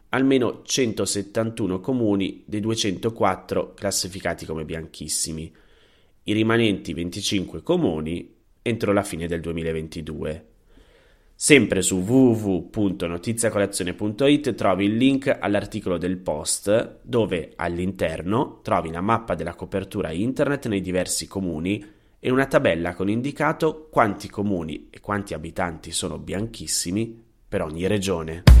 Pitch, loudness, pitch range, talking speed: 100 Hz, -23 LUFS, 85-110 Hz, 110 wpm